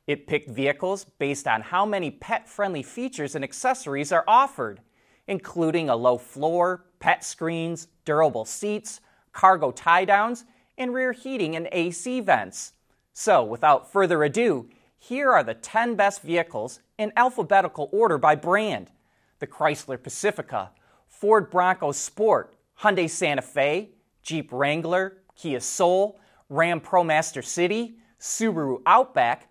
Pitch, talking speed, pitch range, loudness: 180 Hz, 130 wpm, 155-210 Hz, -24 LUFS